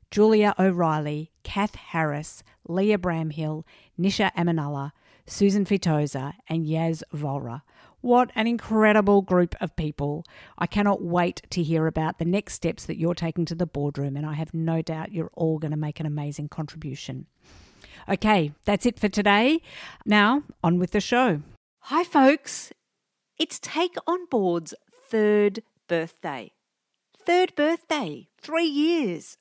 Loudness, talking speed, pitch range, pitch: -25 LUFS, 140 wpm, 160-215 Hz, 175 Hz